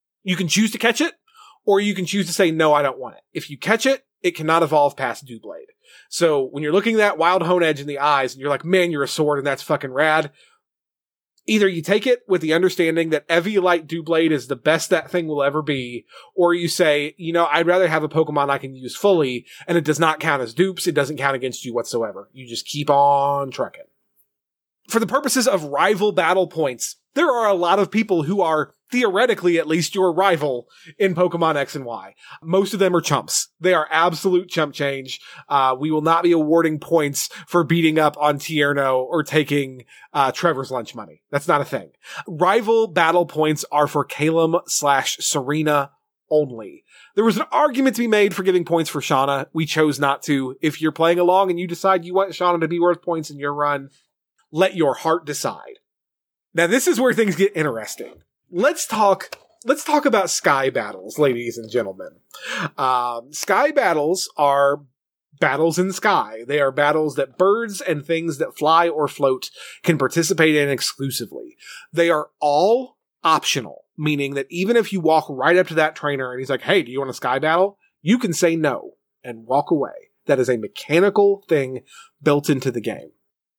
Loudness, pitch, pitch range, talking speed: -19 LUFS, 160 Hz, 145-185 Hz, 205 wpm